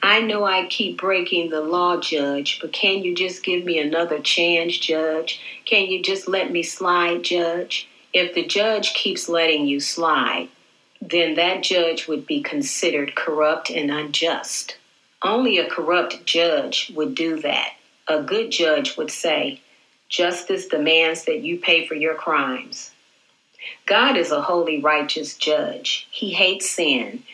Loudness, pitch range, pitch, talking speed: -20 LUFS, 160-190 Hz, 170 Hz, 150 wpm